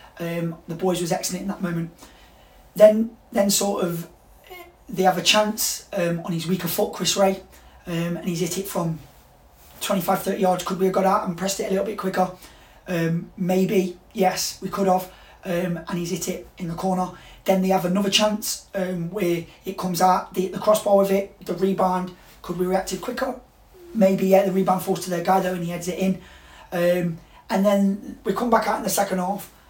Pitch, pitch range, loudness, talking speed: 190 Hz, 180-200 Hz, -23 LUFS, 210 wpm